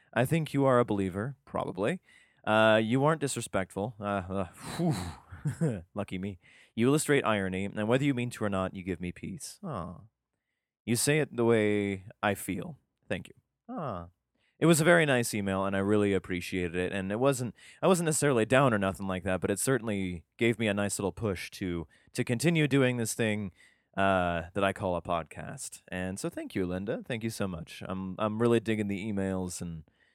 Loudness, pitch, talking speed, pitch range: -30 LUFS, 105 Hz, 195 wpm, 95-125 Hz